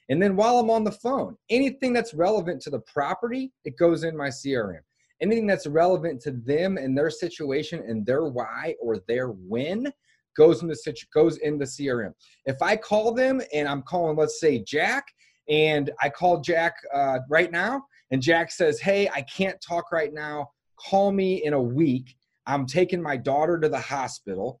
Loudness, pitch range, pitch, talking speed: -25 LUFS, 140-195 Hz, 160 Hz, 190 wpm